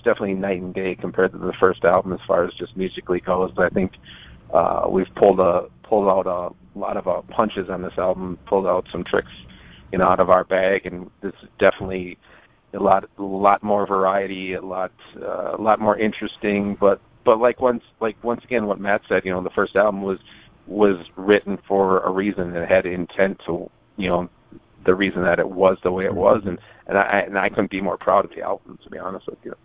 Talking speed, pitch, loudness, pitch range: 225 wpm, 95 Hz, -21 LUFS, 90-100 Hz